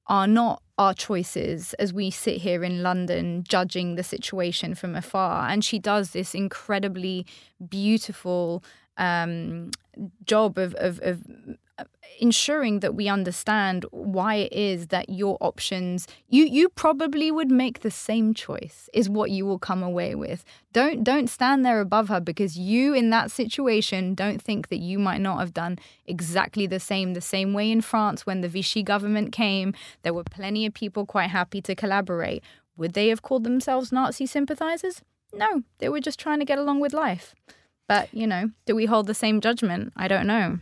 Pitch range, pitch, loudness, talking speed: 185-230 Hz, 205 Hz, -25 LUFS, 180 wpm